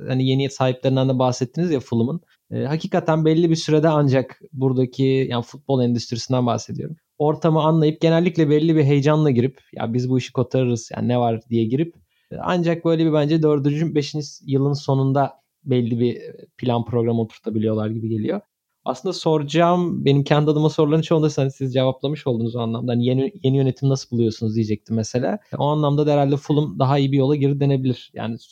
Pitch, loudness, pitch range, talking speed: 135 Hz, -20 LUFS, 125-155 Hz, 180 wpm